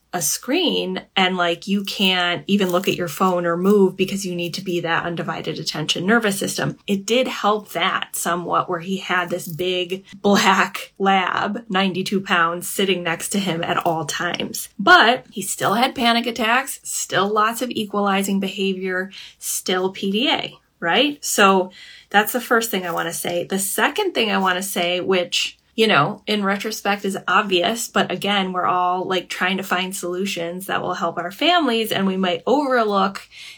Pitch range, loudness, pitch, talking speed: 180-205 Hz, -20 LUFS, 190 Hz, 175 wpm